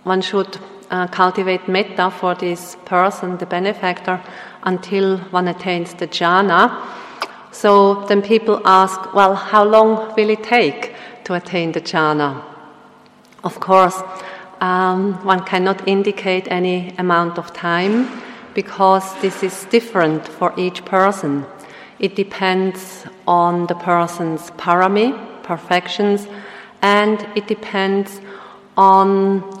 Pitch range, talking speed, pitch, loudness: 180-200 Hz, 115 wpm, 190 Hz, -16 LUFS